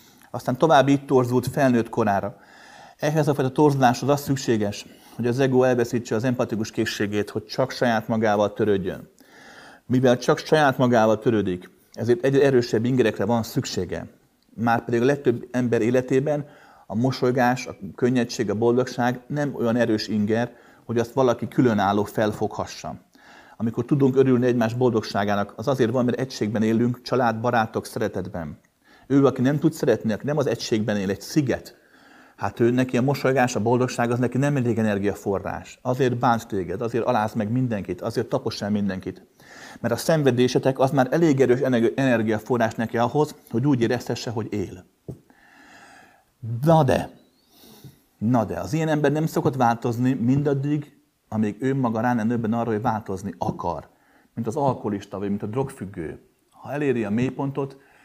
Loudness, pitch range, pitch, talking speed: -23 LUFS, 110-130 Hz, 120 Hz, 155 wpm